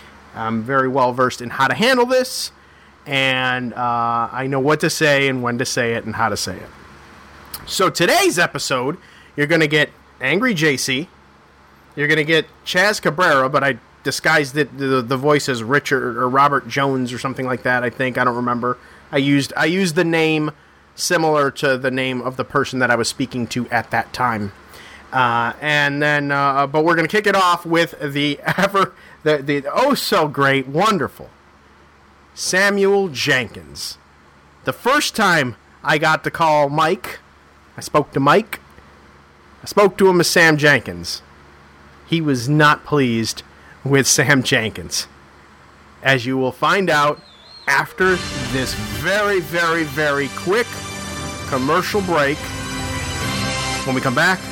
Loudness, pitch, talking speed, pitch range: -18 LUFS, 130 Hz, 165 wpm, 100-150 Hz